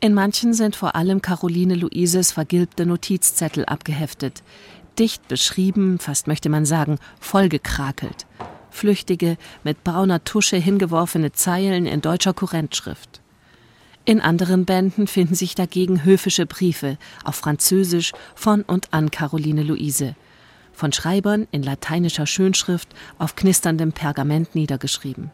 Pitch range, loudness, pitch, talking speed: 155-190 Hz, -20 LUFS, 175 Hz, 120 wpm